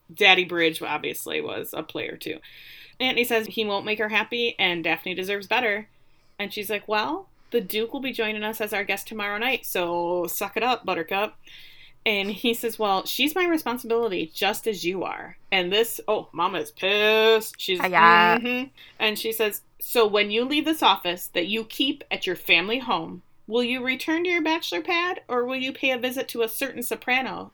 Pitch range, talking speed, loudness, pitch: 195-245 Hz, 200 wpm, -24 LUFS, 220 Hz